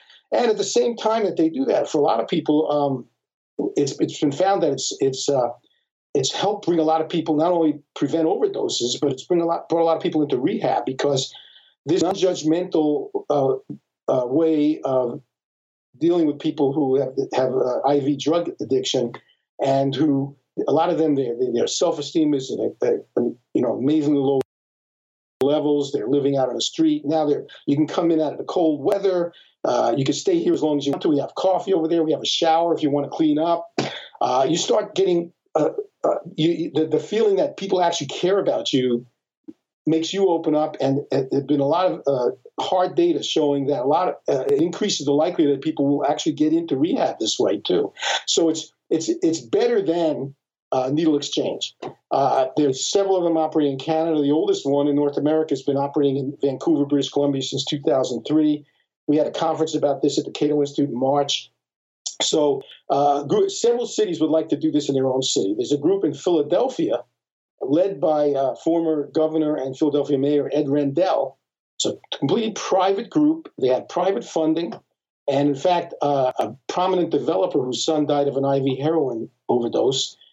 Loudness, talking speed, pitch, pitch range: -21 LUFS, 200 wpm, 155 Hz, 140-180 Hz